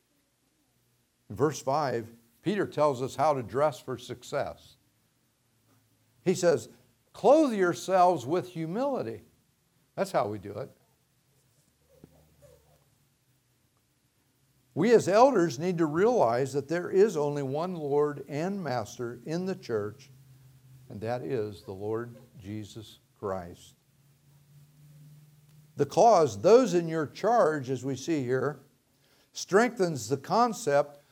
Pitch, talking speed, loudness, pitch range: 140 Hz, 110 wpm, -28 LUFS, 125-165 Hz